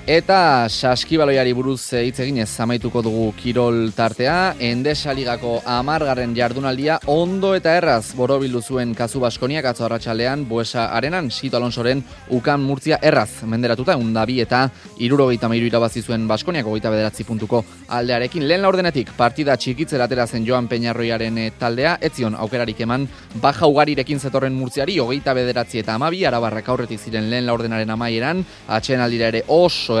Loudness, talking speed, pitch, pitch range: -19 LUFS, 145 wpm, 125 Hz, 115-135 Hz